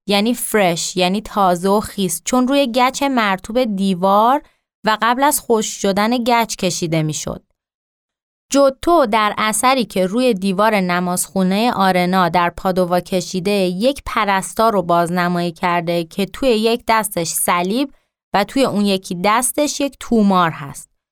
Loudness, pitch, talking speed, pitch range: -17 LUFS, 205 Hz, 135 wpm, 180-240 Hz